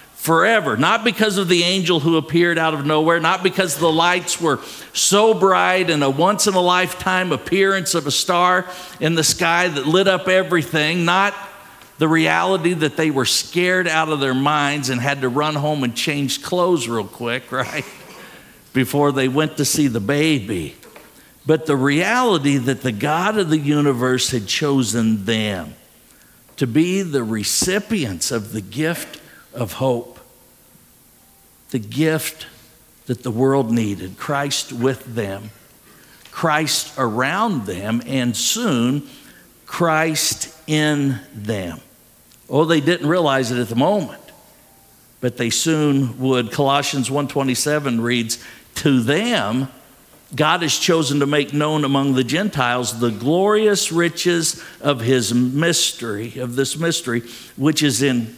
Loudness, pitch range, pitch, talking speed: -18 LUFS, 125-170 Hz, 145 Hz, 145 wpm